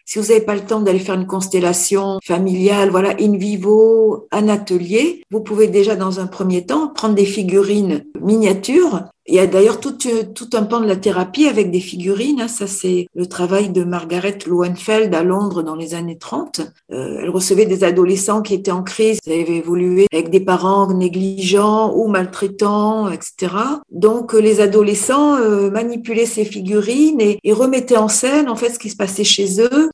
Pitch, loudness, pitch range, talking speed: 205 Hz, -15 LUFS, 185-220 Hz, 185 wpm